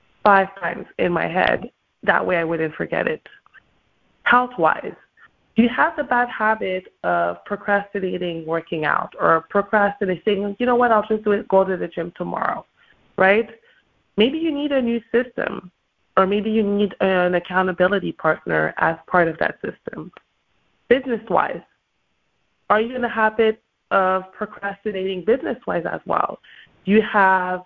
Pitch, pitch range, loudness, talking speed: 200 Hz, 180-220 Hz, -20 LUFS, 155 wpm